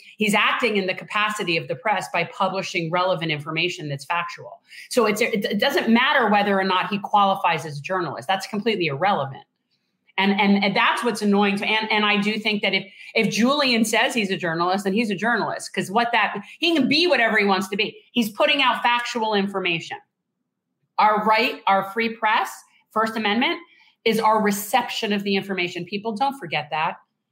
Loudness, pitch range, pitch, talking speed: -21 LUFS, 190-230 Hz, 210 Hz, 190 wpm